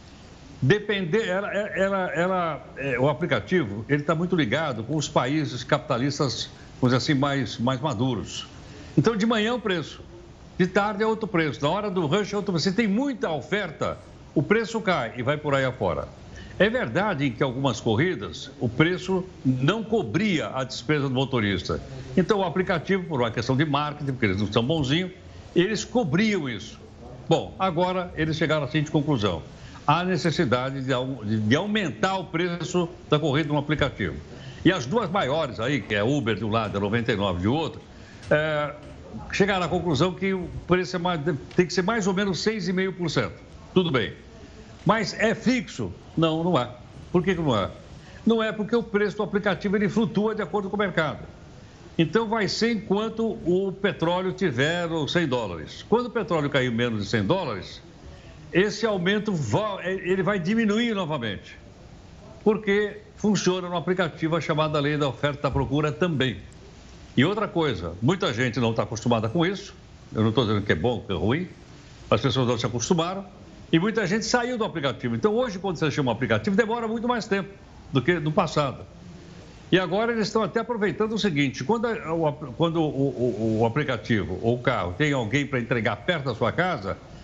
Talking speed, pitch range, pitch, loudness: 185 wpm, 130-195 Hz, 160 Hz, -25 LUFS